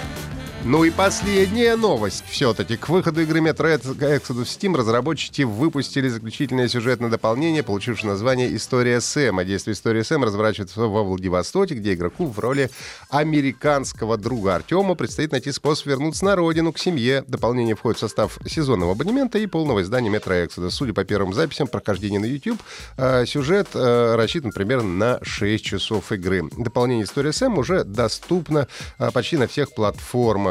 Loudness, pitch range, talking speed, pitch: -21 LUFS, 110-155 Hz, 150 wpm, 125 Hz